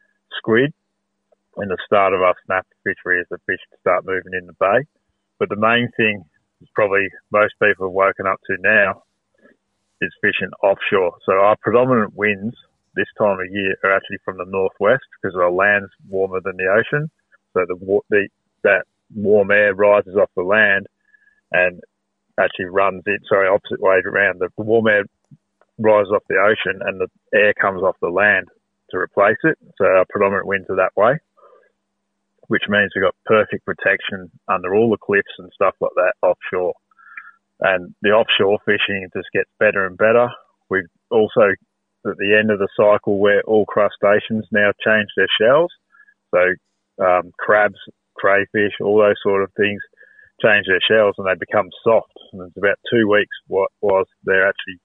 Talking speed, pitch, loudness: 175 wpm, 105 Hz, -17 LUFS